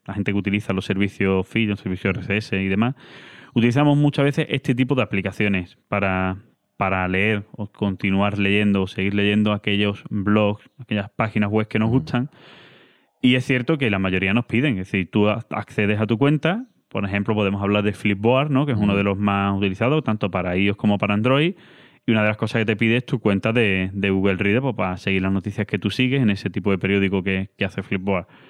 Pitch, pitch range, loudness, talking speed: 105 Hz, 100-120 Hz, -21 LUFS, 215 wpm